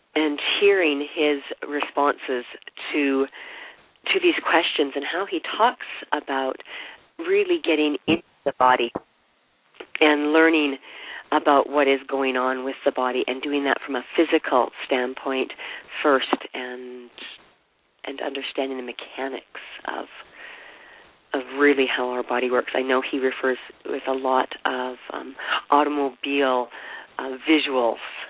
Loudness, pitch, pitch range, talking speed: -23 LUFS, 140 Hz, 130-150 Hz, 125 wpm